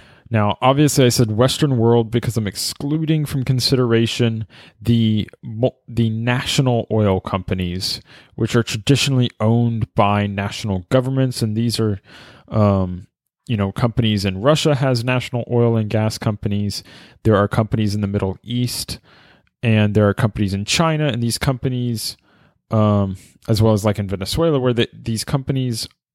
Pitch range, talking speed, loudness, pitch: 105-125 Hz, 150 wpm, -19 LUFS, 115 Hz